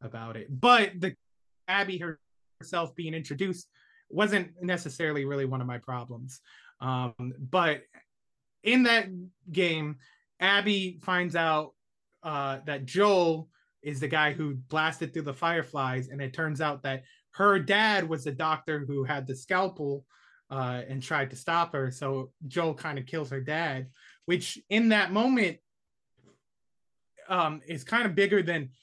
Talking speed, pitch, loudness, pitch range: 150 wpm, 155 Hz, -28 LUFS, 135-180 Hz